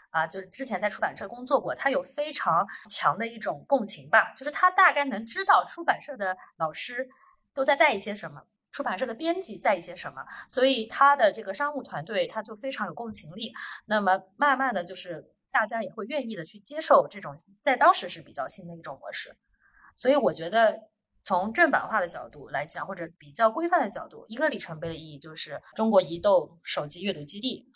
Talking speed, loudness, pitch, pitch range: 320 characters per minute, -26 LUFS, 225 Hz, 185-285 Hz